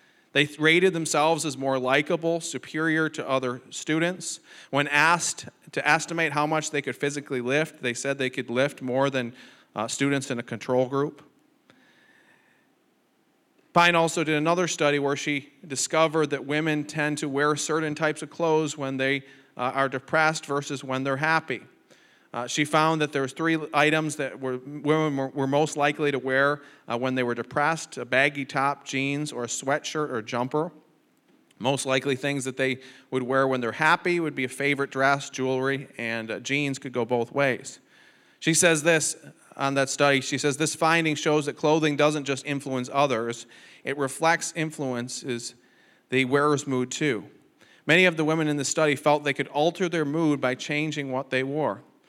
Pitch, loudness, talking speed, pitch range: 145 Hz, -25 LUFS, 180 wpm, 130-155 Hz